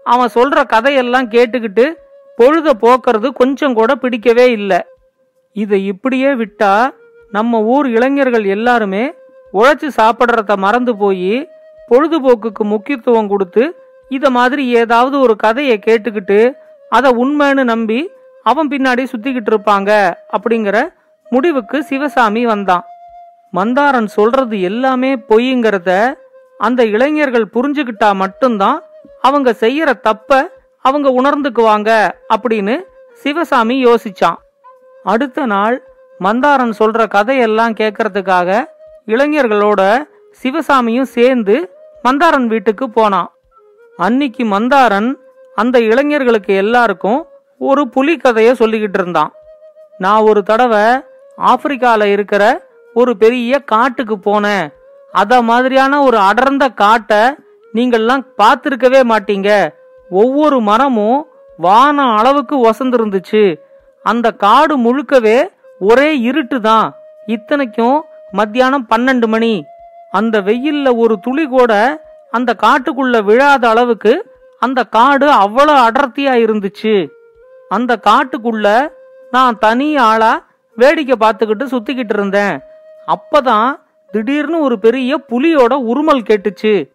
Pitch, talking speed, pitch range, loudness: 250 Hz, 85 wpm, 220-280 Hz, -12 LUFS